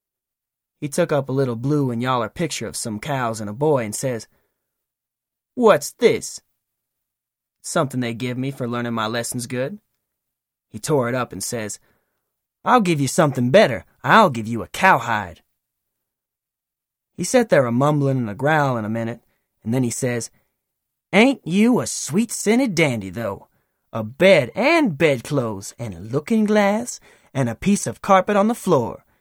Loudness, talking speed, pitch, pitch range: -20 LUFS, 165 wpm, 135 Hz, 115-180 Hz